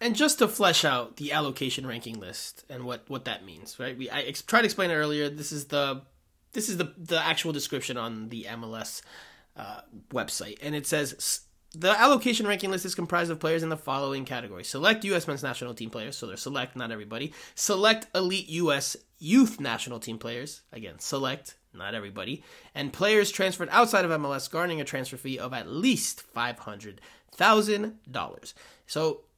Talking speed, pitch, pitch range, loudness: 190 wpm, 150 Hz, 130-190 Hz, -28 LUFS